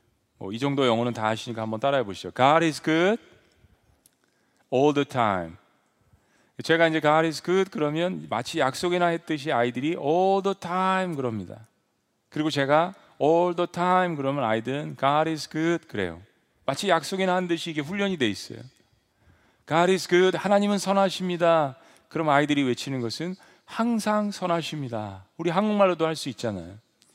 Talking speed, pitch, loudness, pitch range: 400 characters per minute, 155 Hz, -25 LUFS, 120-180 Hz